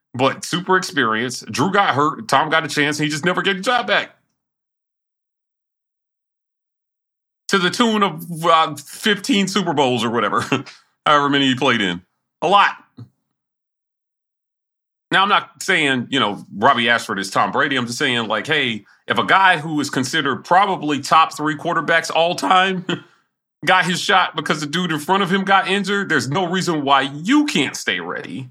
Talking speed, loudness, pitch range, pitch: 175 wpm, -17 LUFS, 140-190 Hz, 160 Hz